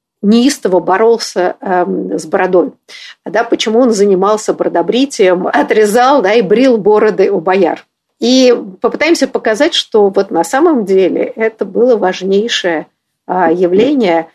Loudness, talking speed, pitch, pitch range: -11 LUFS, 125 wpm, 215 Hz, 185-245 Hz